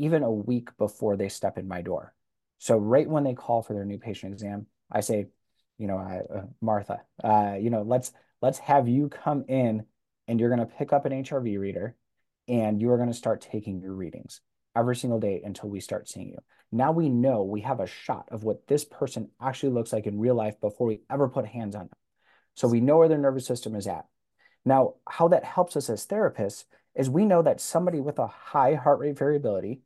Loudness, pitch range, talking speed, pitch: -27 LUFS, 105-135 Hz, 220 wpm, 120 Hz